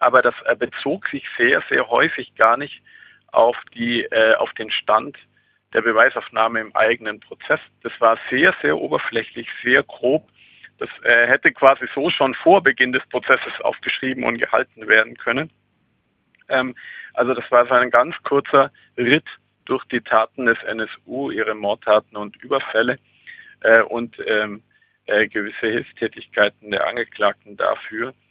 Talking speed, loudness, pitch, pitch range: 145 wpm, -19 LUFS, 115 Hz, 110-125 Hz